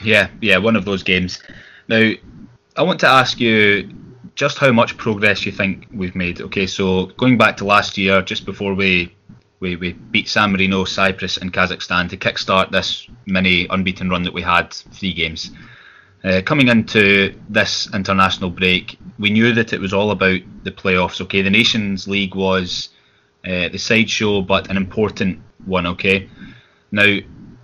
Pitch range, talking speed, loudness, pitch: 95-105 Hz, 170 wpm, -16 LUFS, 95 Hz